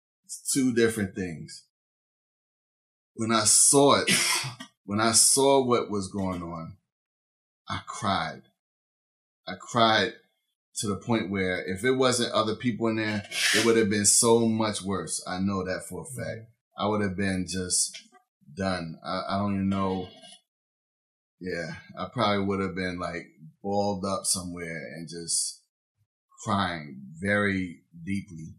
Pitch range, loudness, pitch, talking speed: 95-115 Hz, -25 LUFS, 100 Hz, 145 wpm